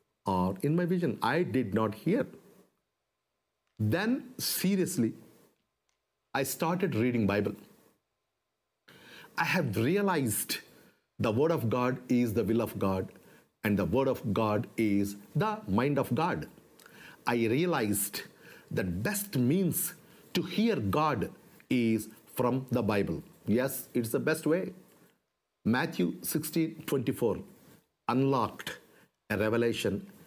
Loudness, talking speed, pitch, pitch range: -31 LUFS, 120 wpm, 125 Hz, 110-165 Hz